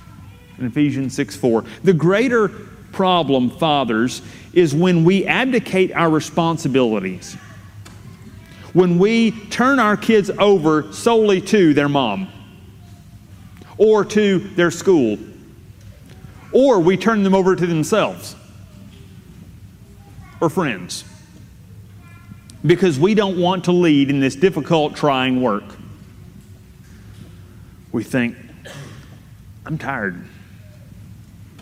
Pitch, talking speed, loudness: 130 Hz, 100 wpm, -17 LUFS